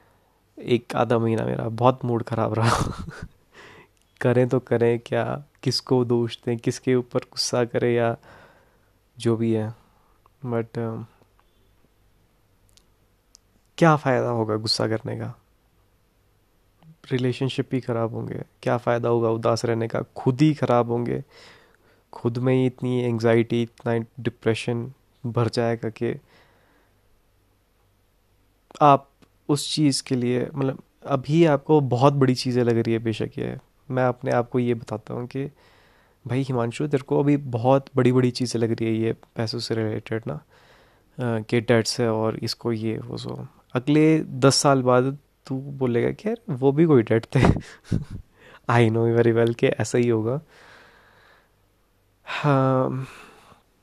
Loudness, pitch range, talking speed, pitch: -23 LUFS, 110-130 Hz, 140 wpm, 120 Hz